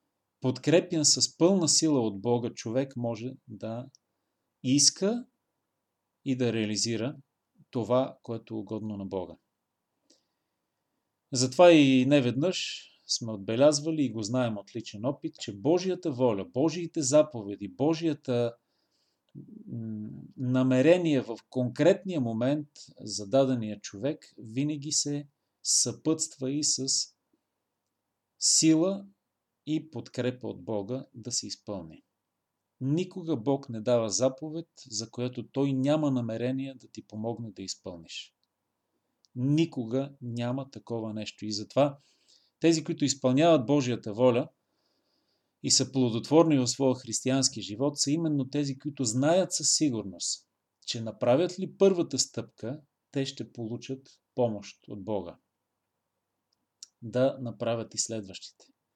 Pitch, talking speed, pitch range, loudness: 130 Hz, 115 wpm, 115-145 Hz, -28 LUFS